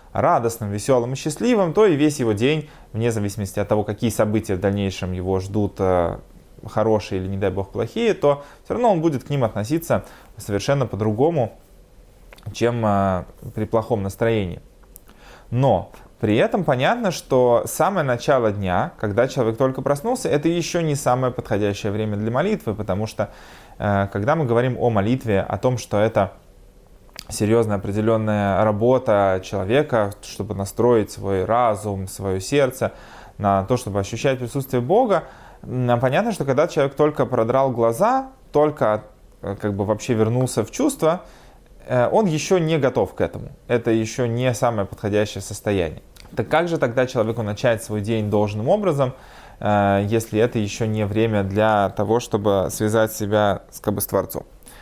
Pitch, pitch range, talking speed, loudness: 110 Hz, 100-130 Hz, 150 wpm, -21 LUFS